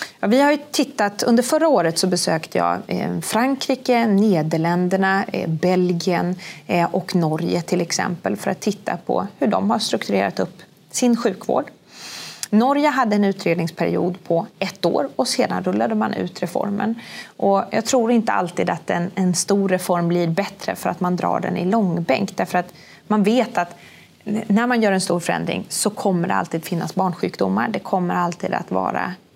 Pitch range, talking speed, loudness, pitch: 175-220 Hz, 170 wpm, -20 LUFS, 190 Hz